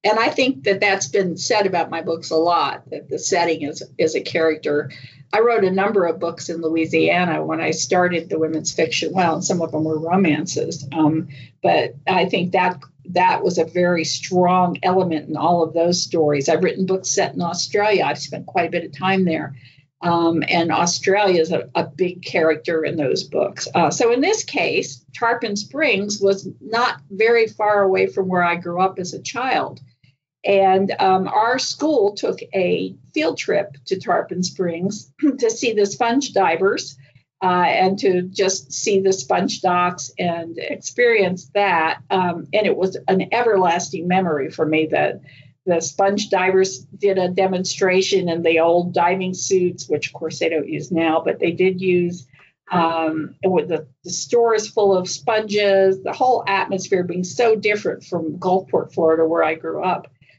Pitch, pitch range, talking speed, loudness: 180 Hz, 160-195 Hz, 180 wpm, -19 LUFS